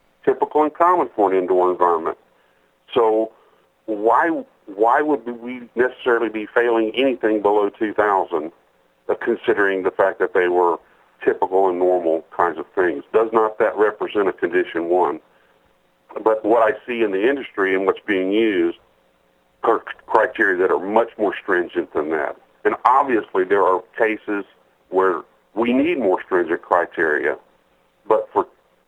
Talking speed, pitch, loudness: 145 wpm, 110 Hz, -19 LUFS